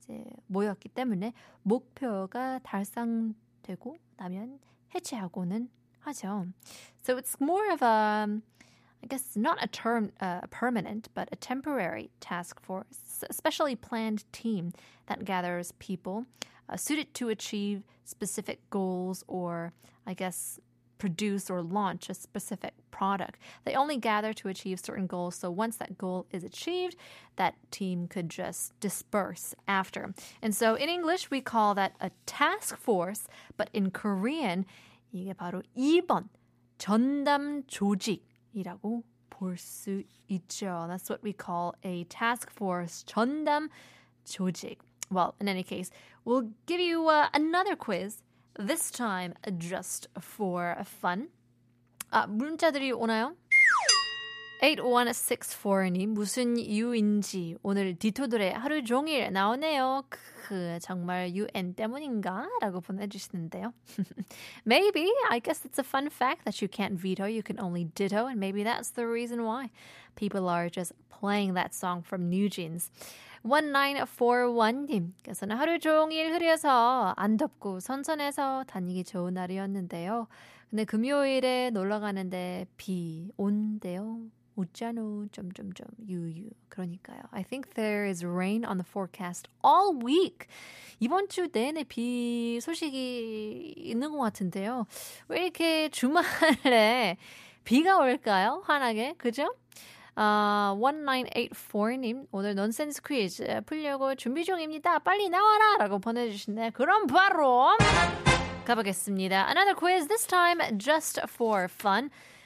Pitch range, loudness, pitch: 190-265 Hz, -30 LUFS, 215 Hz